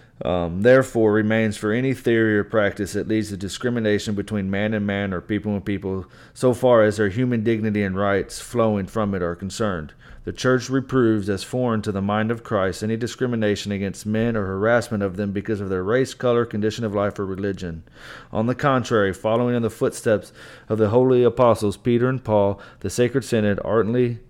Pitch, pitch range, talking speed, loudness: 110 Hz, 100-120 Hz, 195 wpm, -22 LUFS